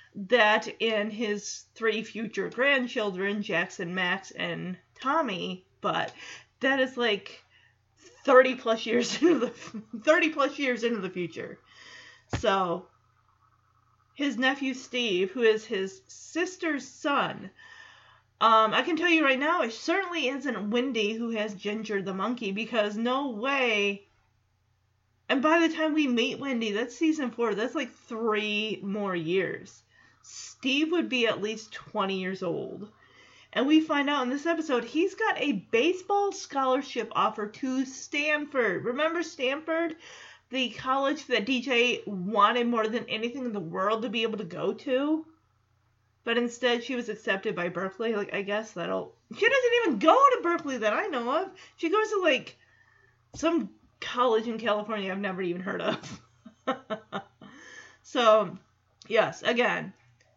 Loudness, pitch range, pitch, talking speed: -27 LUFS, 205-280 Hz, 235 Hz, 145 wpm